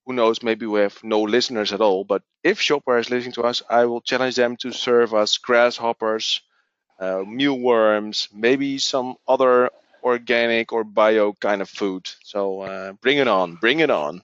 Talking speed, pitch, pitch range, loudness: 180 wpm, 115 Hz, 105-125 Hz, -20 LUFS